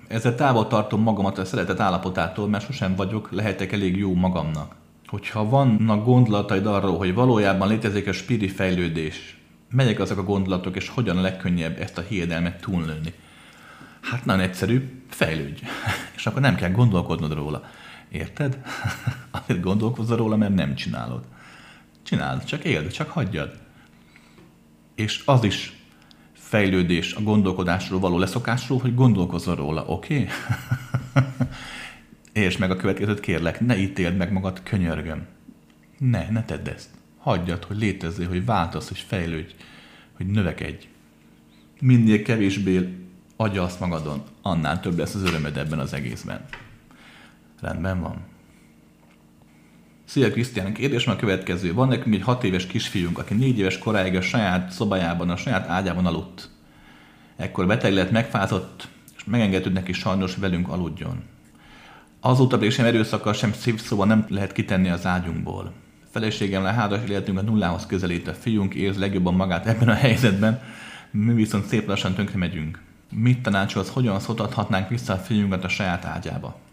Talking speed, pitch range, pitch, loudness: 145 wpm, 85-110 Hz, 95 Hz, -23 LUFS